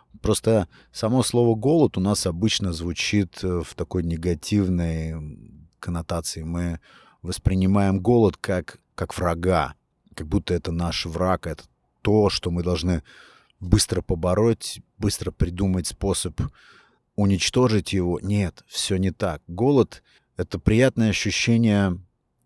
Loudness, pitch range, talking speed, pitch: -23 LUFS, 85-105 Hz, 115 wpm, 95 Hz